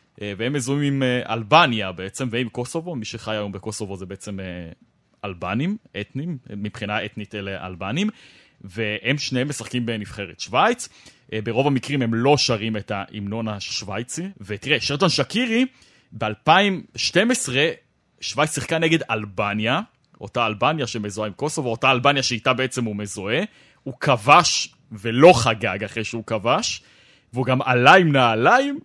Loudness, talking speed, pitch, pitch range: -21 LUFS, 130 wpm, 120 Hz, 105-140 Hz